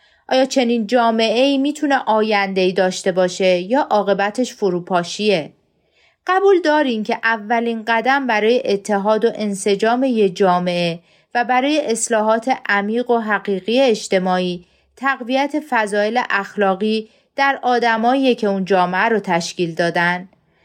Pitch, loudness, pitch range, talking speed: 220 Hz, -17 LUFS, 195-250 Hz, 115 wpm